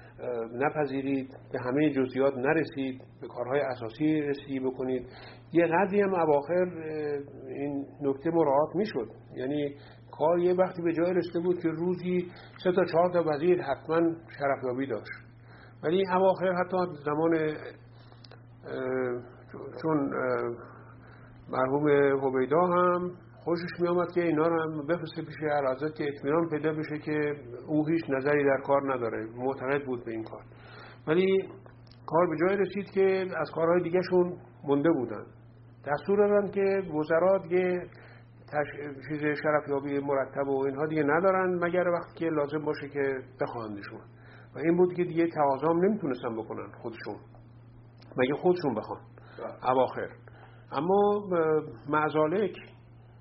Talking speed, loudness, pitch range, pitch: 130 wpm, -29 LUFS, 125-170 Hz, 145 Hz